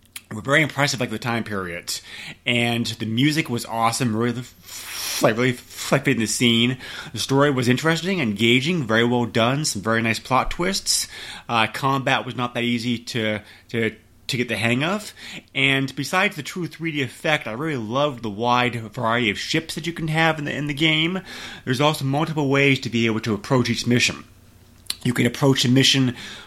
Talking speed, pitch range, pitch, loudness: 195 wpm, 115-145 Hz, 125 Hz, -21 LUFS